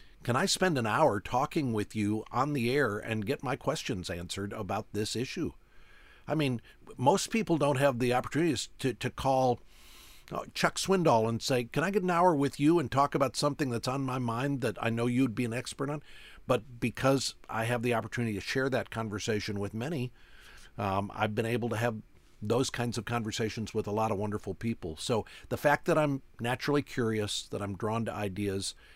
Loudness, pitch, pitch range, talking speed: -31 LUFS, 120 Hz, 110-140 Hz, 200 wpm